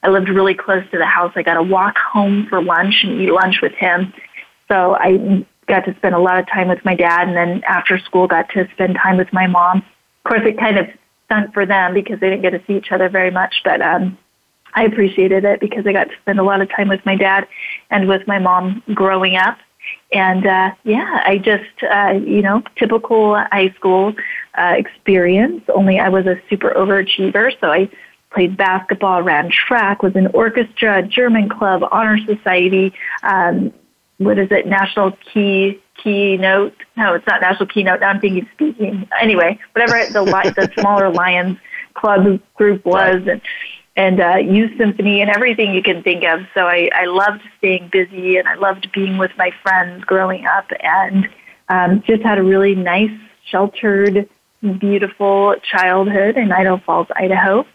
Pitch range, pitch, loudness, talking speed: 185-205 Hz, 195 Hz, -14 LUFS, 185 wpm